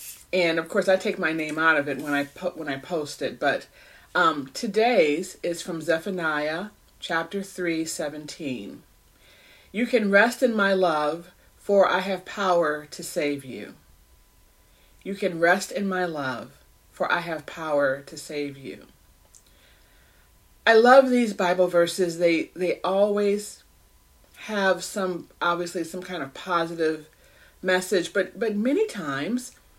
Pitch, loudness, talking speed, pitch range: 175 Hz, -24 LUFS, 145 wpm, 145-195 Hz